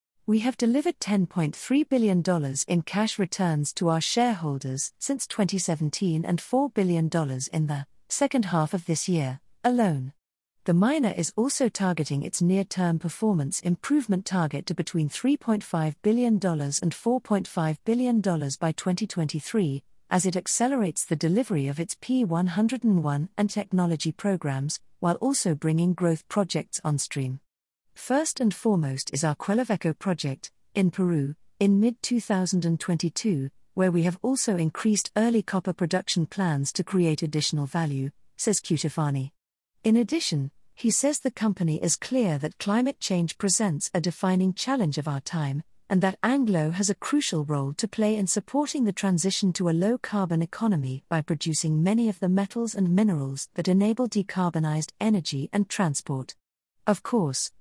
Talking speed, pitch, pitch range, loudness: 145 wpm, 180 Hz, 155-215 Hz, -26 LUFS